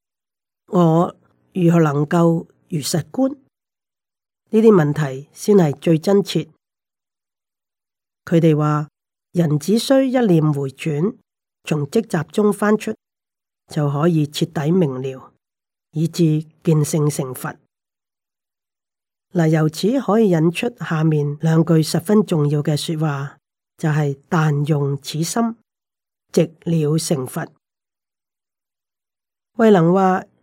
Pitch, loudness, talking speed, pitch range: 165 Hz, -18 LUFS, 155 characters per minute, 150-185 Hz